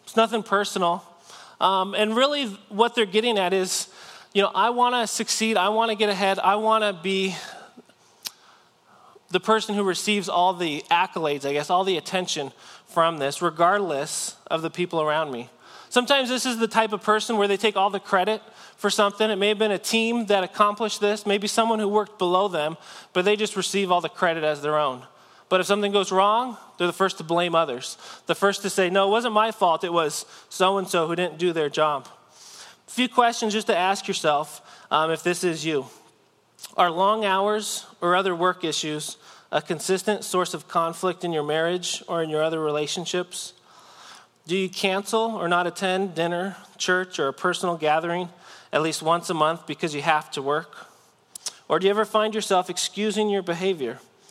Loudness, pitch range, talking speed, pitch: -23 LUFS, 170-210 Hz, 200 wpm, 190 Hz